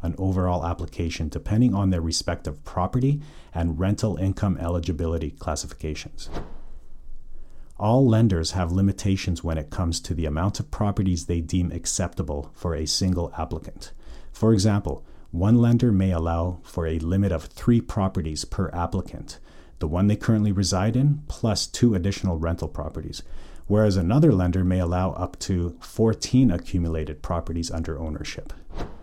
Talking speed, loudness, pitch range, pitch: 145 wpm, -24 LUFS, 80-100 Hz, 90 Hz